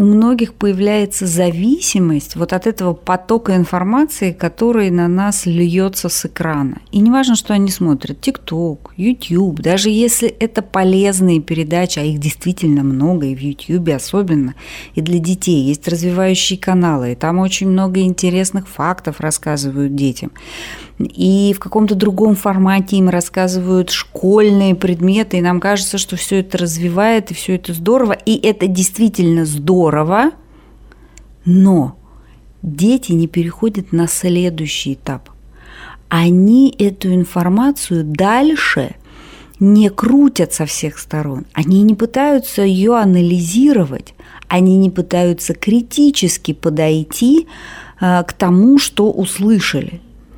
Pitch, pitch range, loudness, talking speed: 185 Hz, 170-205 Hz, -14 LUFS, 125 wpm